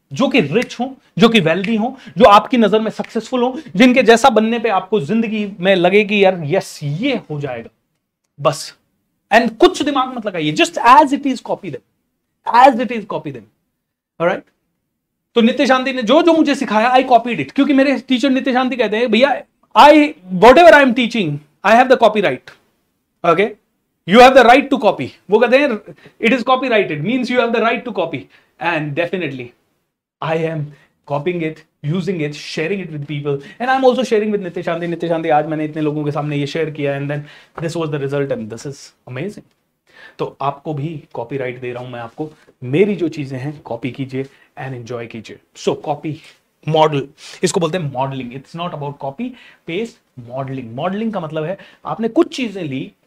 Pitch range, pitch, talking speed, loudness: 150-240 Hz, 190 Hz, 200 wpm, -15 LUFS